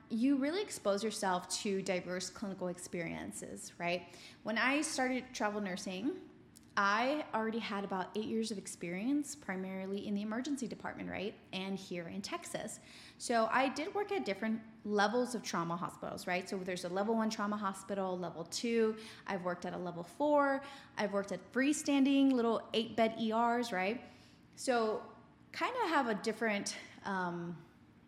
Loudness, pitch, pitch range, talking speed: -36 LUFS, 210 Hz, 190-245 Hz, 160 wpm